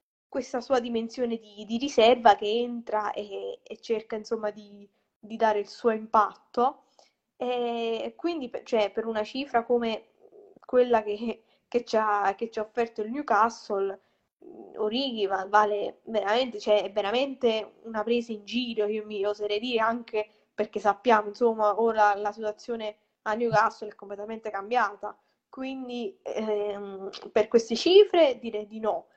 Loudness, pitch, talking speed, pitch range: -27 LUFS, 225 Hz, 140 wpm, 210-240 Hz